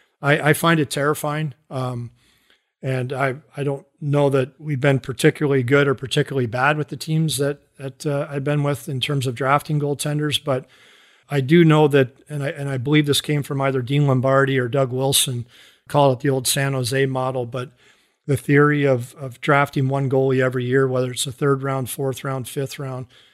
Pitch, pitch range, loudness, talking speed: 140 Hz, 130-145 Hz, -20 LUFS, 200 wpm